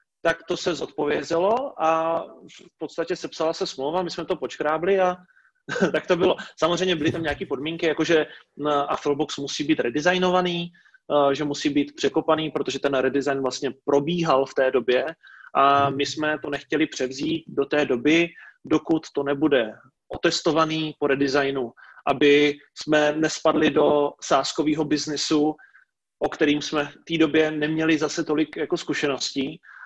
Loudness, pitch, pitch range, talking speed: -23 LUFS, 155 Hz, 145-165 Hz, 145 wpm